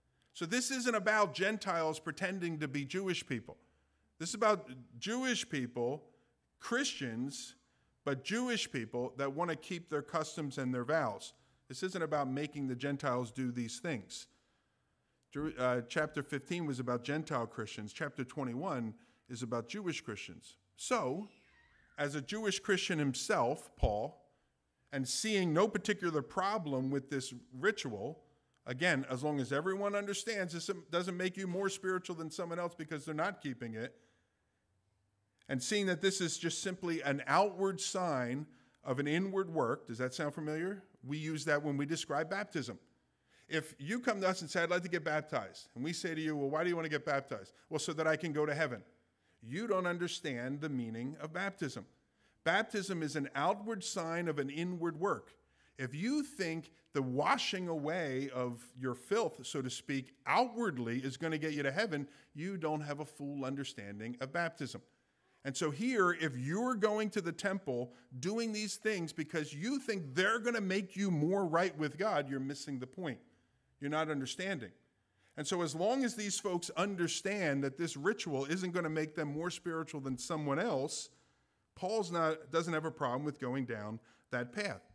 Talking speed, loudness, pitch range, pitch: 175 wpm, -37 LUFS, 130-185 Hz, 155 Hz